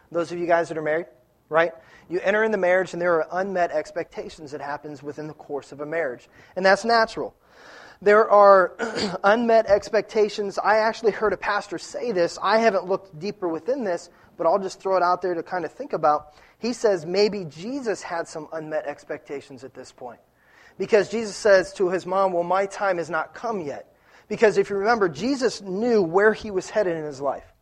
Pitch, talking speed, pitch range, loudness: 185 Hz, 205 wpm, 165-210 Hz, -23 LUFS